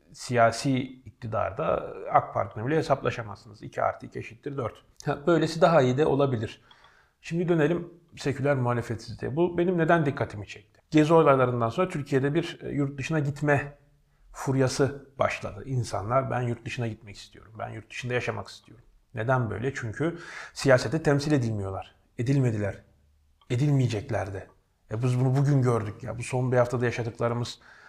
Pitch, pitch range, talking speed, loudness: 125 Hz, 110-145 Hz, 140 wpm, -27 LUFS